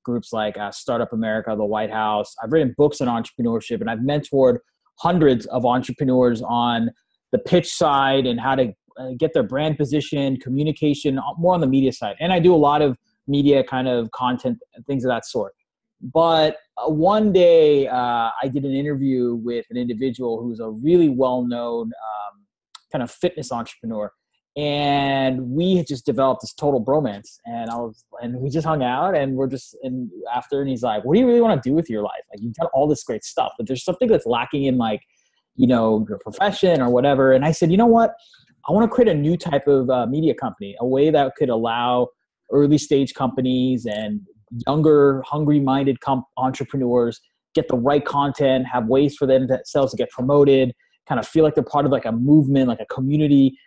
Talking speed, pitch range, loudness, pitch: 205 wpm, 120-150 Hz, -20 LUFS, 135 Hz